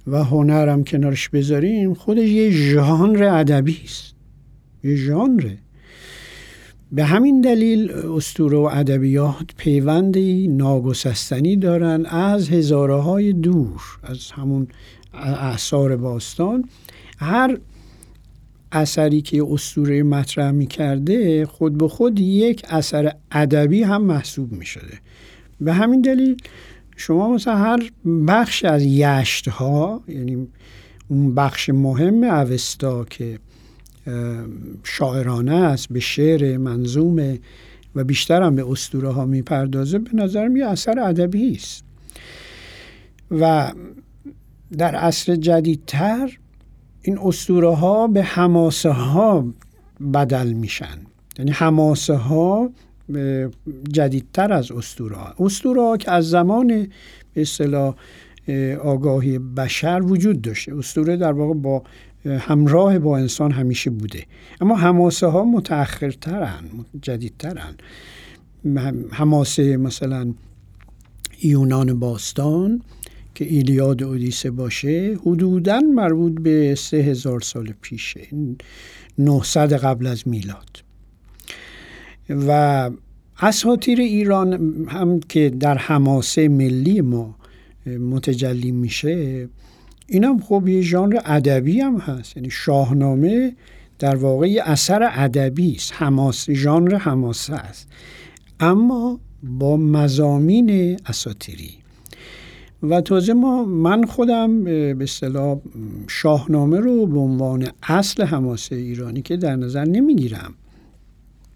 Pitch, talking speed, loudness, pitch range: 145 Hz, 105 wpm, -18 LUFS, 130-175 Hz